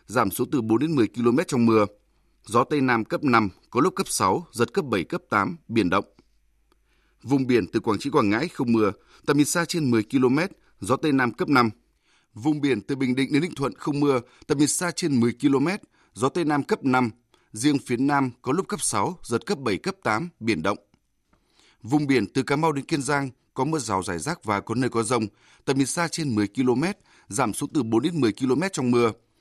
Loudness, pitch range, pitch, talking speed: -24 LUFS, 115-150 Hz, 130 Hz, 230 wpm